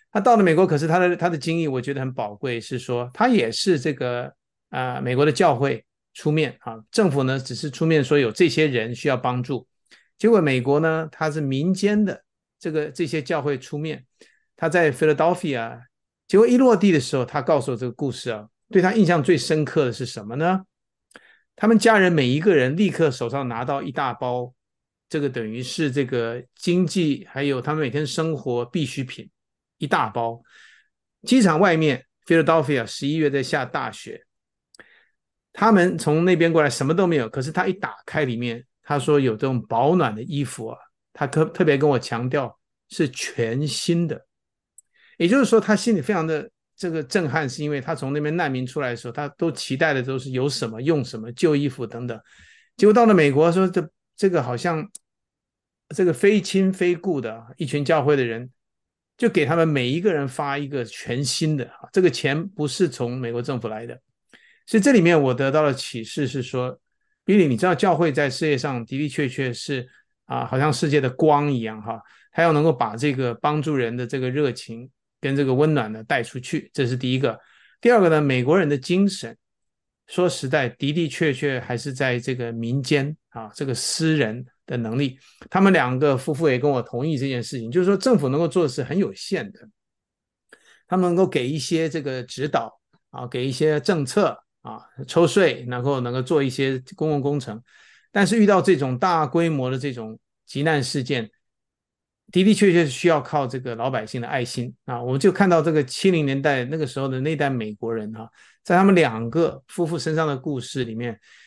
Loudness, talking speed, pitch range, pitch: -22 LUFS, 295 characters per minute, 130-170 Hz, 145 Hz